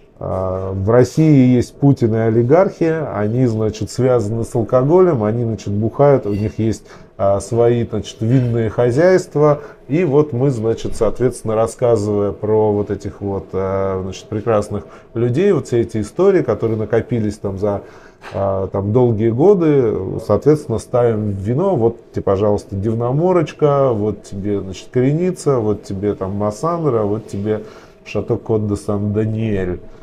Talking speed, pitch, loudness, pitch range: 130 wpm, 110 Hz, -17 LUFS, 105-125 Hz